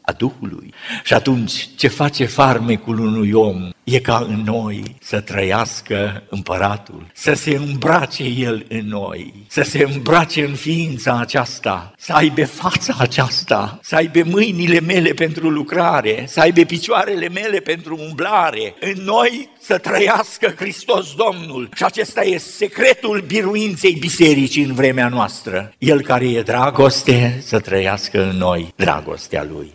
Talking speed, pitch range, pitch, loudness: 140 wpm, 110-165 Hz, 135 Hz, -16 LUFS